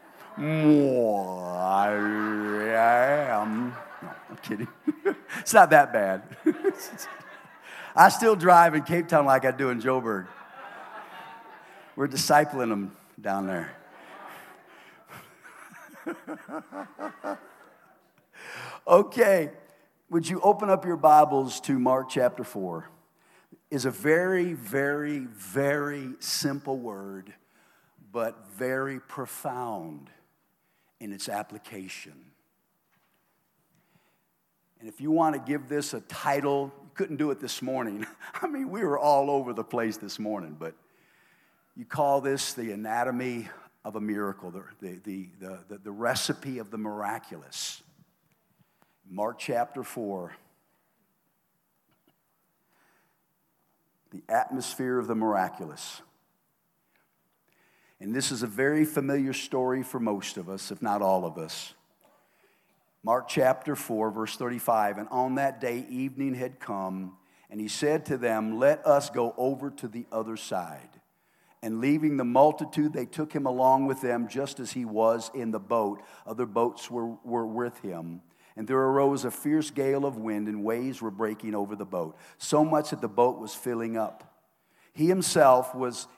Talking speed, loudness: 135 wpm, -27 LUFS